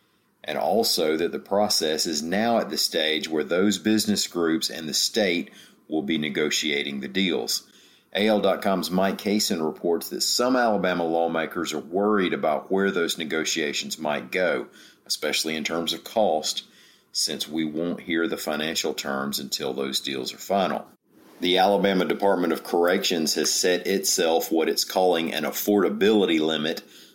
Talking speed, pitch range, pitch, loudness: 155 wpm, 80-95 Hz, 85 Hz, -24 LUFS